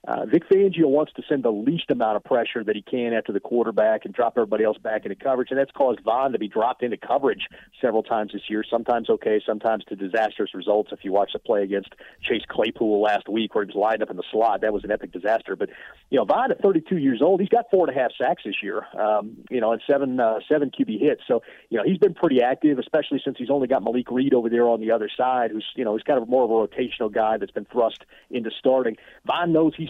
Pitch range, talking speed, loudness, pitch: 110-150 Hz, 265 wpm, -23 LUFS, 120 Hz